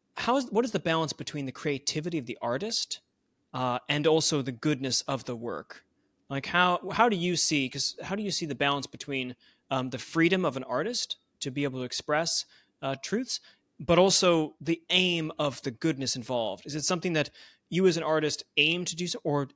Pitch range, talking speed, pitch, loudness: 135-175 Hz, 210 wpm, 155 Hz, -28 LUFS